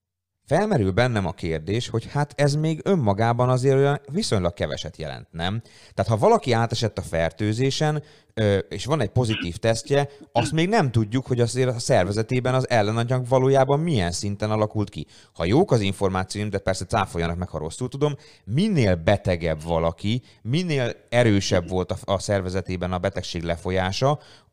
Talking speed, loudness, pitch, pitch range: 155 wpm, -23 LUFS, 110 Hz, 95-130 Hz